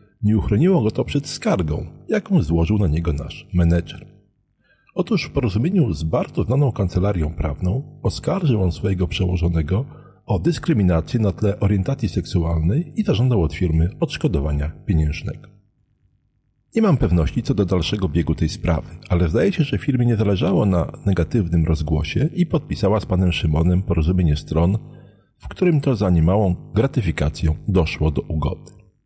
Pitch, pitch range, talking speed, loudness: 95 Hz, 85-120 Hz, 145 wpm, -20 LUFS